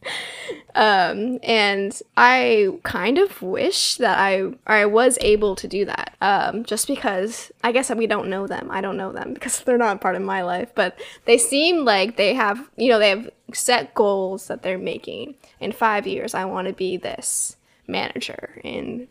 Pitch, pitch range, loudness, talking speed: 215 Hz, 195-250 Hz, -20 LUFS, 185 wpm